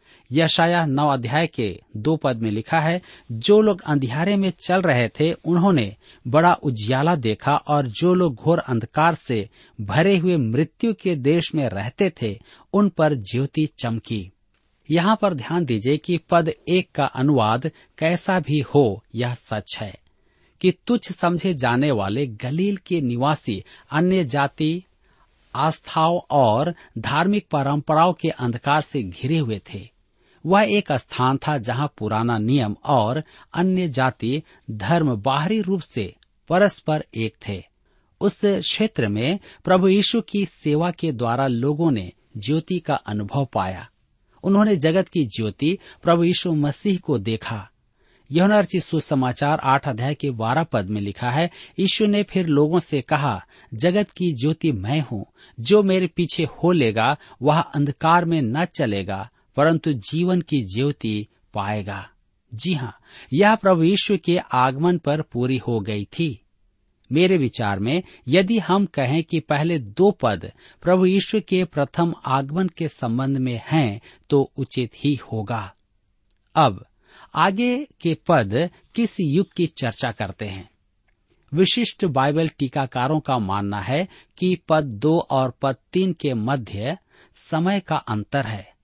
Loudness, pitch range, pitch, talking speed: -21 LUFS, 120-175 Hz, 145 Hz, 145 wpm